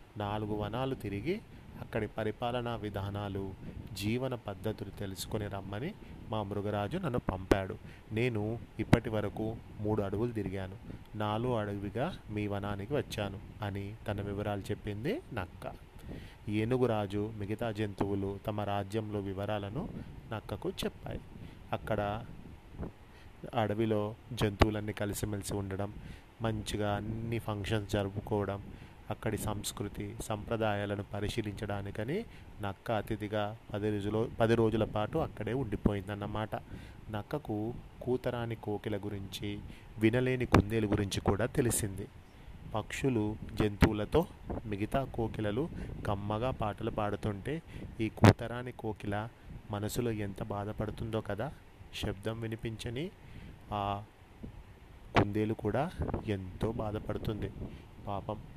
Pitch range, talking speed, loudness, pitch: 100-115 Hz, 95 wpm, -35 LUFS, 105 Hz